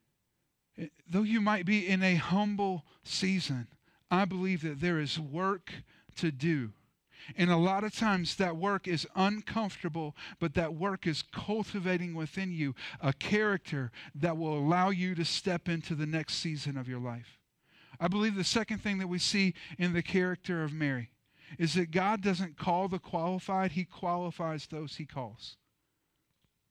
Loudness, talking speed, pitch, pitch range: -32 LUFS, 165 wpm, 175 Hz, 155-190 Hz